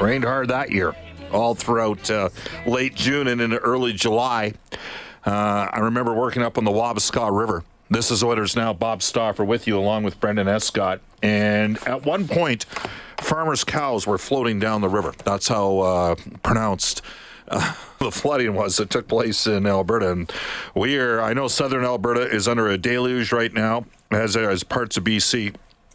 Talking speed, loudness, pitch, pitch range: 175 wpm, -21 LUFS, 110 Hz, 105-120 Hz